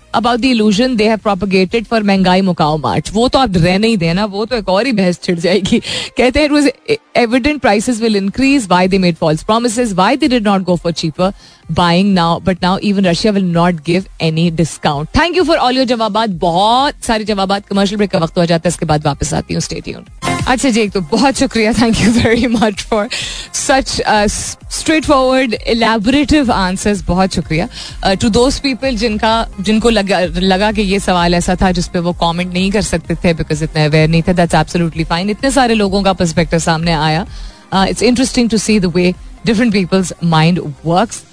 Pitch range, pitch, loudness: 175-235 Hz, 200 Hz, -13 LUFS